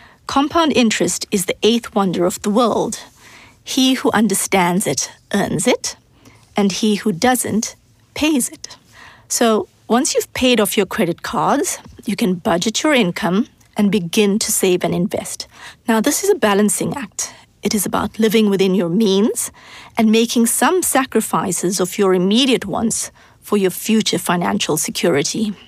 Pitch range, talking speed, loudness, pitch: 195-240 Hz, 155 wpm, -17 LUFS, 215 Hz